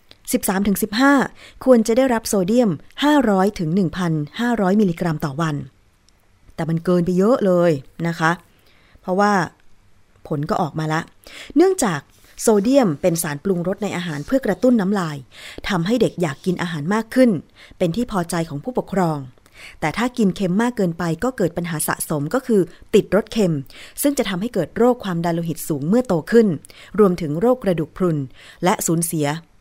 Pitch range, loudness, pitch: 160-215 Hz, -20 LUFS, 180 Hz